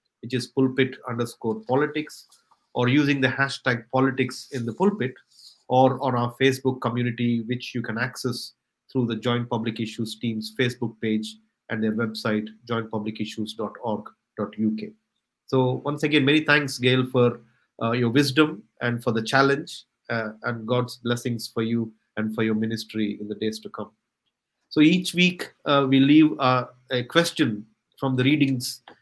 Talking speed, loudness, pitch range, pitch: 155 wpm, -24 LUFS, 115-135 Hz, 125 Hz